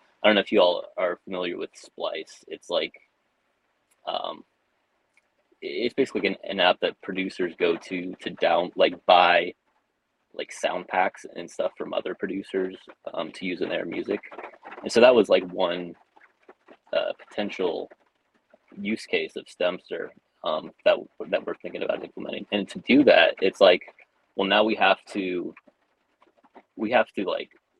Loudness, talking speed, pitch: -25 LUFS, 160 wpm, 305 Hz